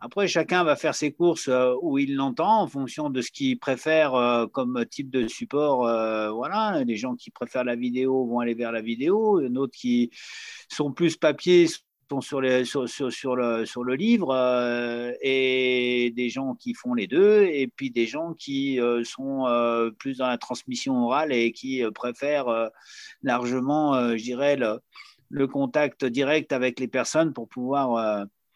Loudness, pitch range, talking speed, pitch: -25 LUFS, 120-155 Hz, 190 wpm, 130 Hz